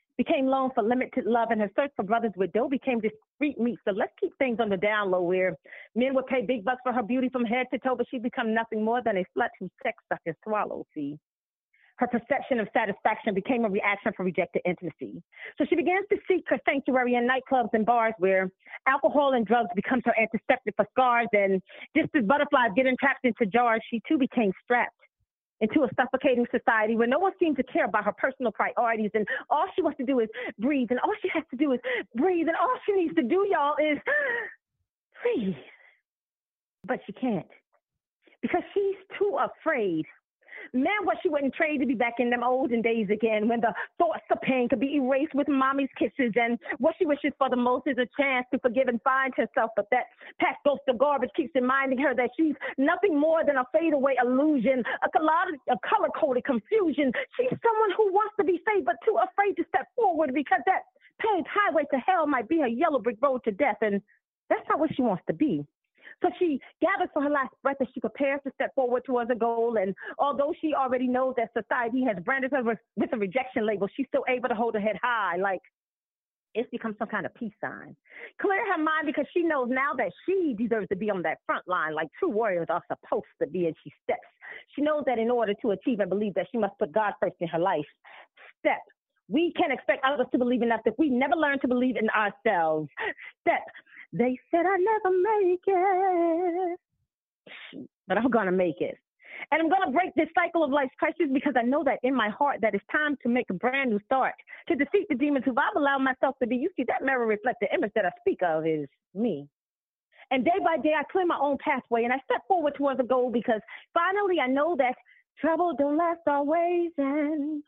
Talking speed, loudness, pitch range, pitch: 220 wpm, -27 LUFS, 230-315 Hz, 265 Hz